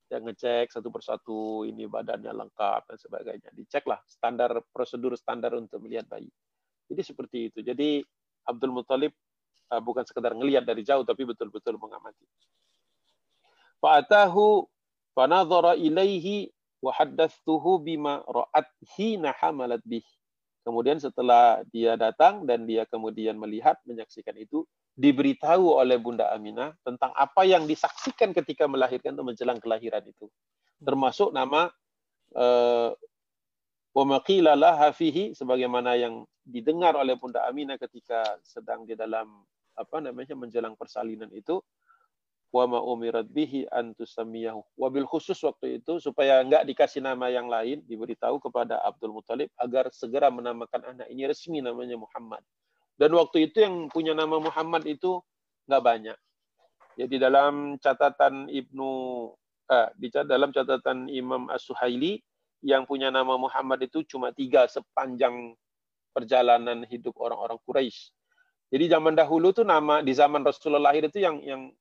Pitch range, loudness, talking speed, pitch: 120-160 Hz, -26 LUFS, 130 wpm, 135 Hz